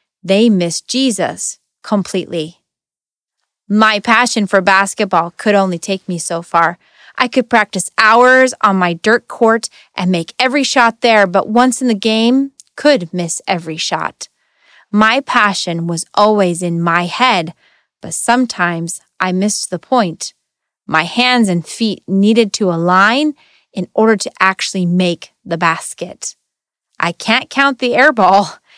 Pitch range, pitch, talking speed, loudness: 175-235 Hz, 200 Hz, 145 wpm, -13 LUFS